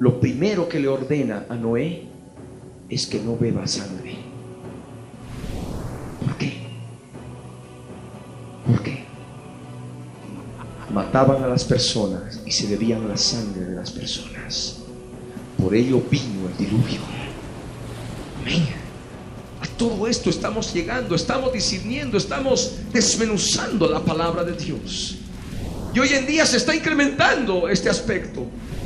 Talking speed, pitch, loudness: 115 wpm, 135 Hz, -22 LUFS